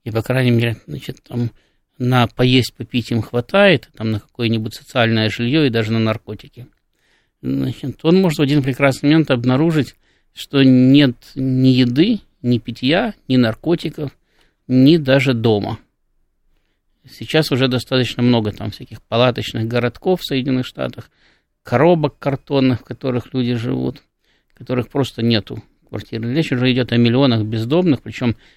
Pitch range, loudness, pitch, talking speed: 115-140 Hz, -17 LUFS, 125 Hz, 145 wpm